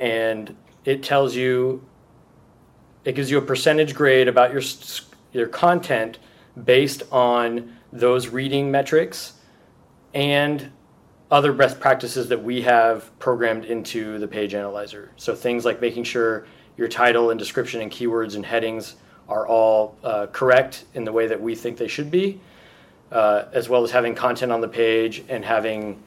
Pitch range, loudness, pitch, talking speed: 115-135 Hz, -21 LUFS, 120 Hz, 155 wpm